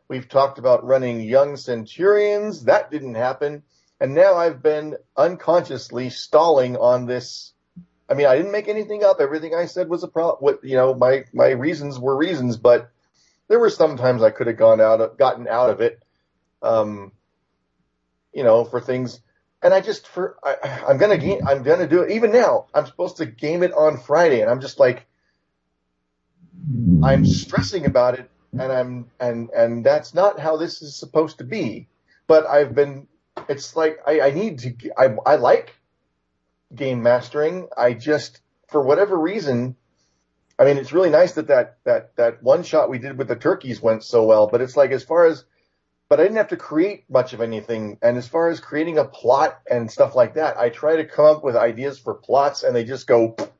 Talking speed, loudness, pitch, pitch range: 195 wpm, -19 LUFS, 135 Hz, 120-165 Hz